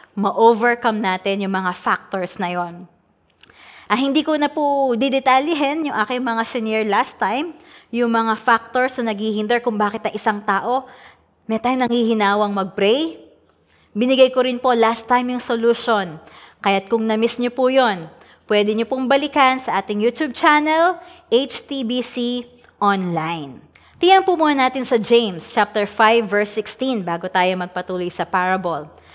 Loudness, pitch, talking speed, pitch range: -18 LUFS, 230 Hz, 150 wpm, 200-255 Hz